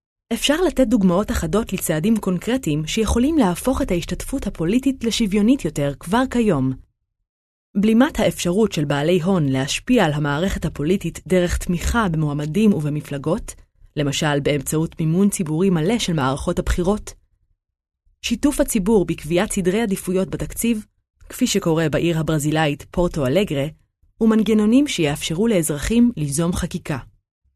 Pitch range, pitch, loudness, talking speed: 150-220 Hz, 180 Hz, -20 LUFS, 115 wpm